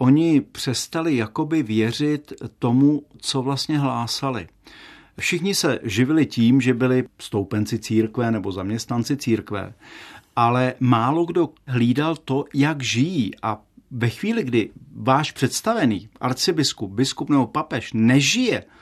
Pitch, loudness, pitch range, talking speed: 130 Hz, -21 LUFS, 115-145 Hz, 120 wpm